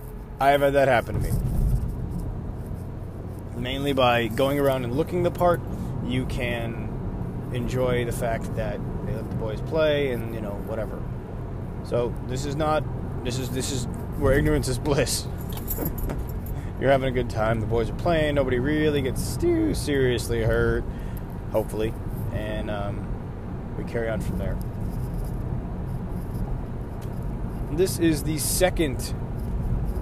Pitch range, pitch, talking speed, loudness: 110-140 Hz, 120 Hz, 140 wpm, -26 LUFS